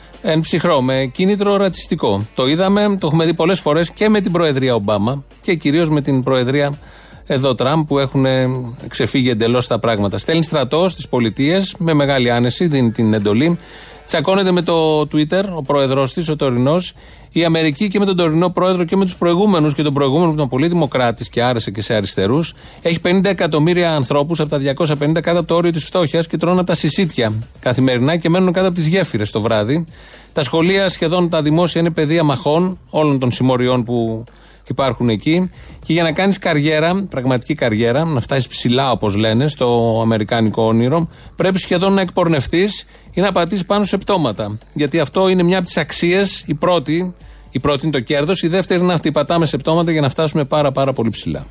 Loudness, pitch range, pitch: -16 LUFS, 130-175 Hz, 155 Hz